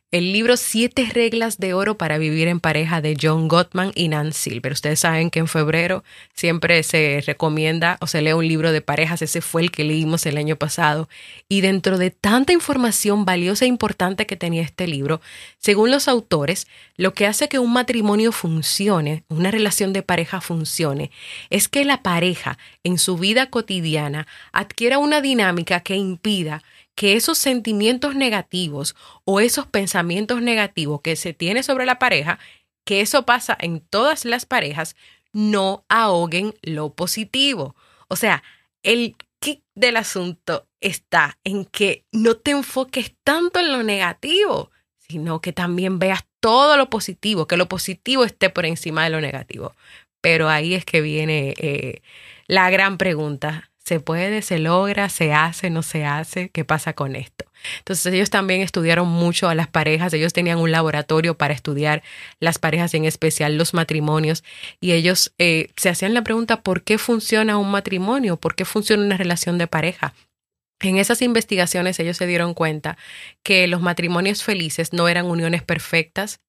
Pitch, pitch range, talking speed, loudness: 180 Hz, 160-215 Hz, 165 wpm, -19 LUFS